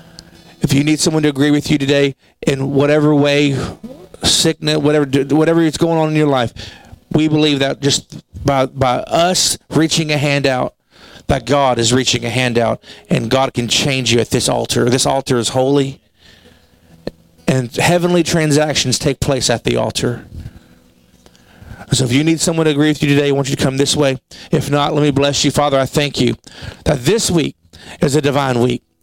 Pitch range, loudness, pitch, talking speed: 125-150 Hz, -15 LUFS, 140 Hz, 190 wpm